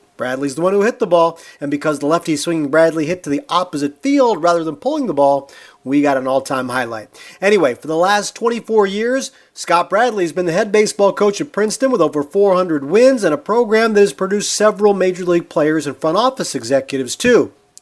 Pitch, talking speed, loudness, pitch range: 175 Hz, 215 wpm, -16 LUFS, 145-210 Hz